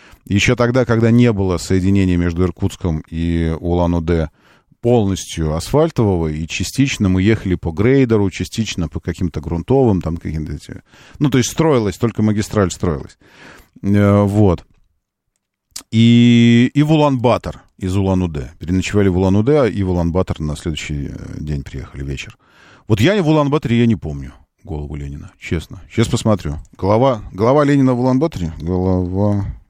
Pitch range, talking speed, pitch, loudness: 85-115 Hz, 135 wpm, 95 Hz, -16 LUFS